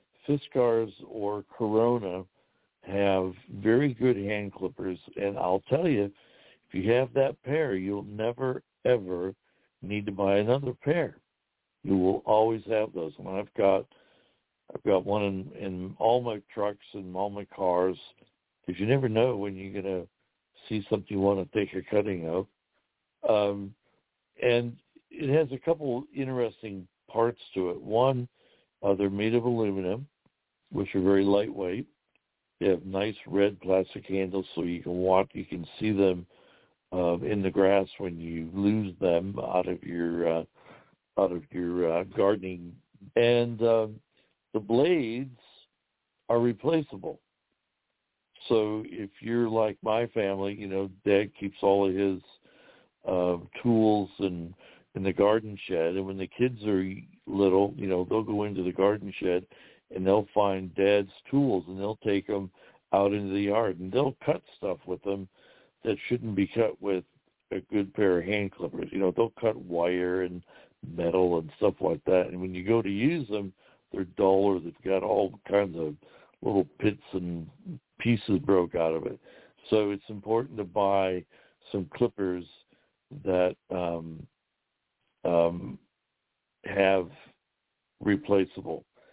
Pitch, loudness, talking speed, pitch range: 100 Hz, -28 LUFS, 155 wpm, 95-110 Hz